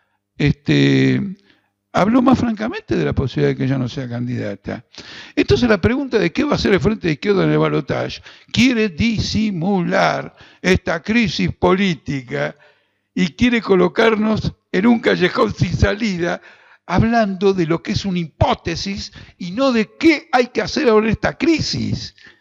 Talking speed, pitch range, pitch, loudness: 160 wpm, 150-225 Hz, 195 Hz, -18 LUFS